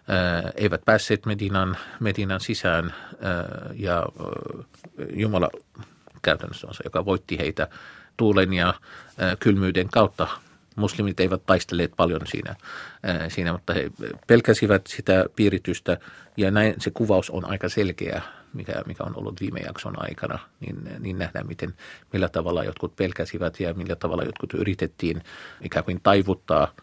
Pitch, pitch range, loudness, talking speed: 95 Hz, 90-105 Hz, -25 LUFS, 130 wpm